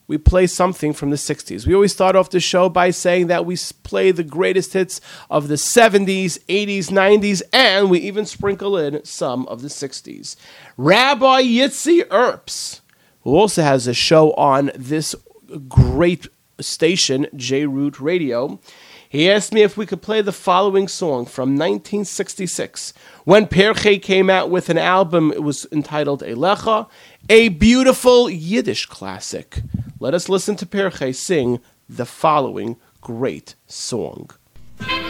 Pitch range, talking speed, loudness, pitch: 150-200 Hz, 145 wpm, -16 LUFS, 180 Hz